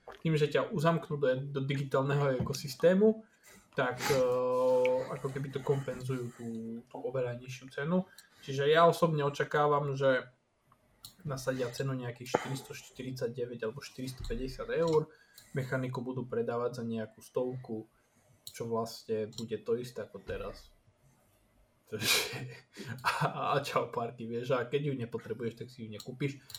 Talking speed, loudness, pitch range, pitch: 135 wpm, -33 LUFS, 120-145 Hz, 130 Hz